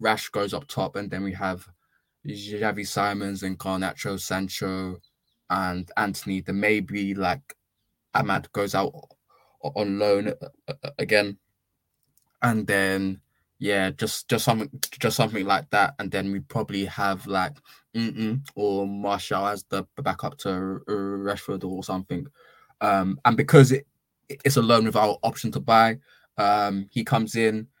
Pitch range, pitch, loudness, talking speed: 95-110 Hz, 100 Hz, -25 LUFS, 140 wpm